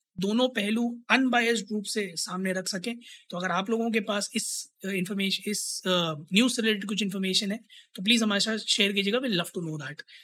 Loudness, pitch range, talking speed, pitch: -27 LUFS, 190-225 Hz, 190 wpm, 205 Hz